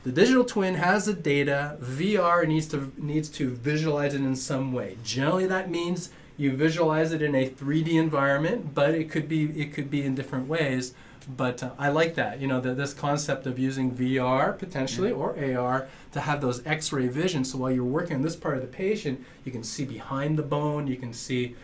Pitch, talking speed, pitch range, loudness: 145 Hz, 210 wpm, 130-160 Hz, -27 LUFS